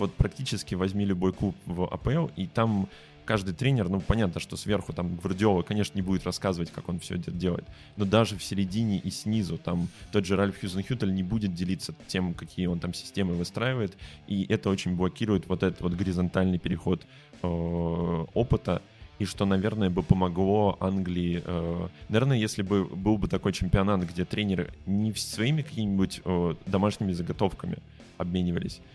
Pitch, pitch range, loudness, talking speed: 95 Hz, 90-105 Hz, -29 LUFS, 165 wpm